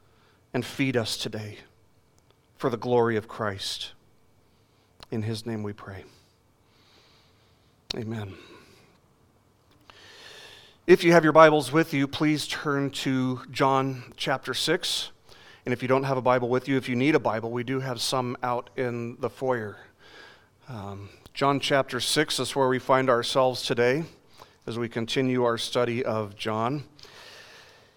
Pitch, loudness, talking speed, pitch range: 125 Hz, -25 LUFS, 145 wpm, 115-135 Hz